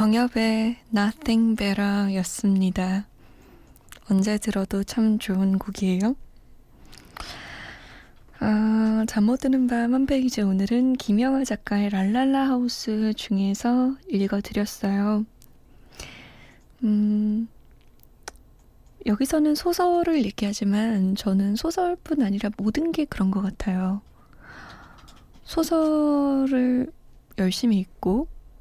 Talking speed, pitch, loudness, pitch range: 220 characters per minute, 220 Hz, -23 LUFS, 200-255 Hz